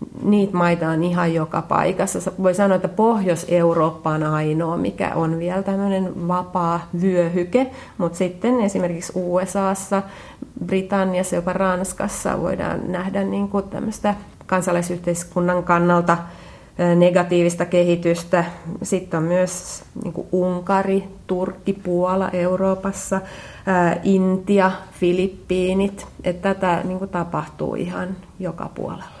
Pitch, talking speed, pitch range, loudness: 185 Hz, 95 wpm, 175-195 Hz, -21 LUFS